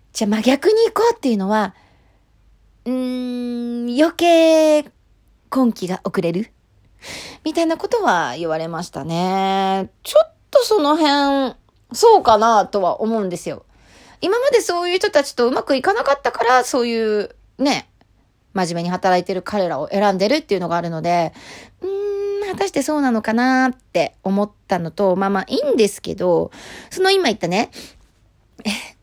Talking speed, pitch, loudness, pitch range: 310 characters per minute, 240 Hz, -18 LUFS, 195-310 Hz